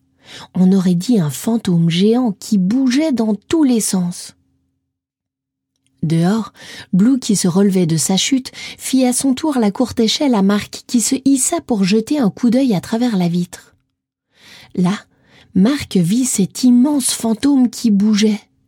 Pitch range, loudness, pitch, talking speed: 185-250 Hz, -15 LUFS, 215 Hz, 155 wpm